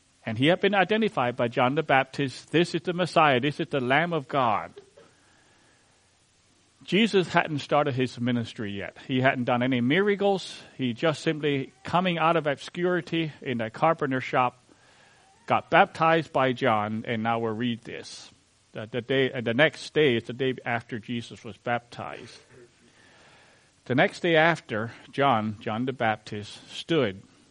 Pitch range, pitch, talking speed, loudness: 115-160 Hz, 130 Hz, 160 wpm, -25 LUFS